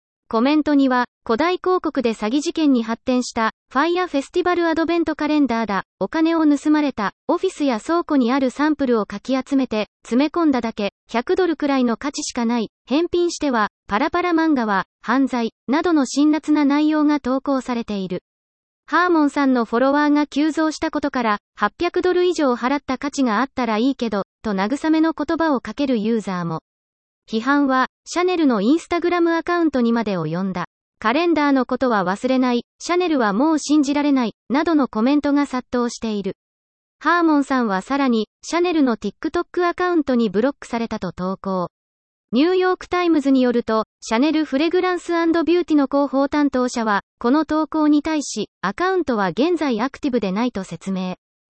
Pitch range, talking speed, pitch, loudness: 230-315 Hz, 395 characters per minute, 275 Hz, -20 LUFS